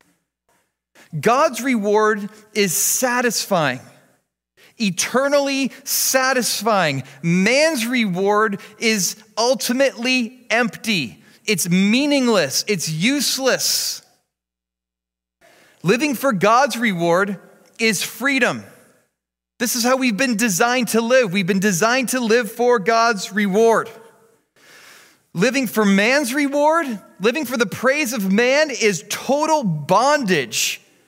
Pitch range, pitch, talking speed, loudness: 200-255 Hz, 225 Hz, 95 wpm, -18 LUFS